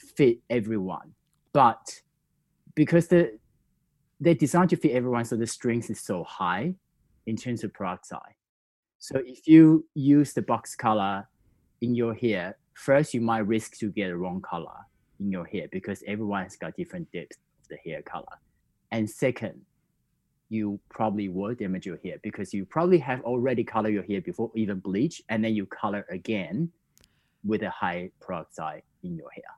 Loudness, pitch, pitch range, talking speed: -27 LUFS, 115 Hz, 105-150 Hz, 170 wpm